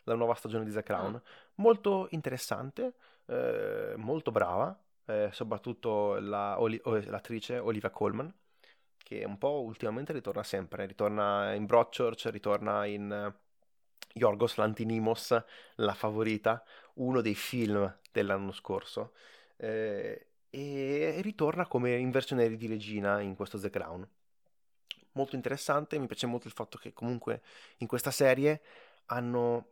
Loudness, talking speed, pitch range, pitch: -33 LUFS, 130 wpm, 105-135 Hz, 115 Hz